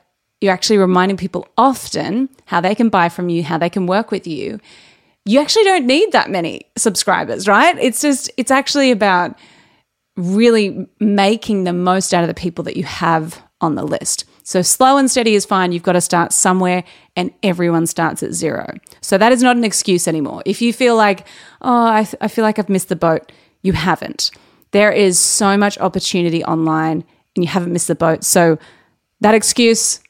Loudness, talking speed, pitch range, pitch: -15 LUFS, 195 wpm, 175-220 Hz, 190 Hz